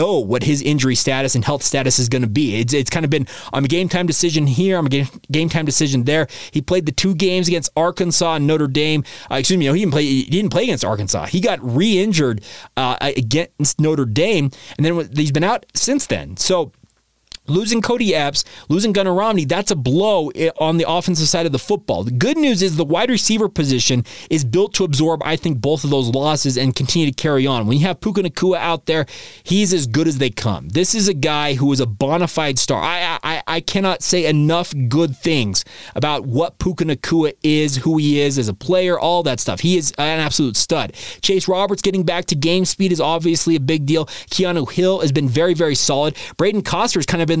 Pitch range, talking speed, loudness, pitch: 140-180 Hz, 225 wpm, -17 LUFS, 160 Hz